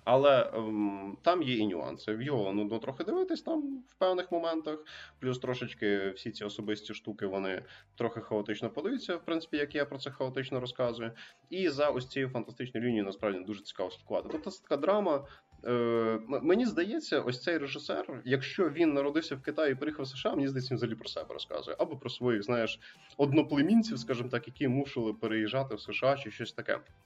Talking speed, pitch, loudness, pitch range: 180 wpm, 125 Hz, -33 LUFS, 110-145 Hz